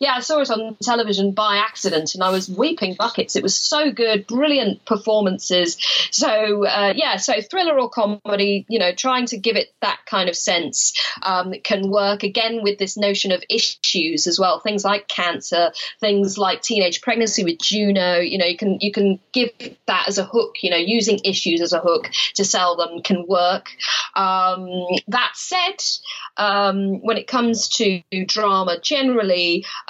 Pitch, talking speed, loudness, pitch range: 205 Hz, 180 wpm, -19 LUFS, 185-230 Hz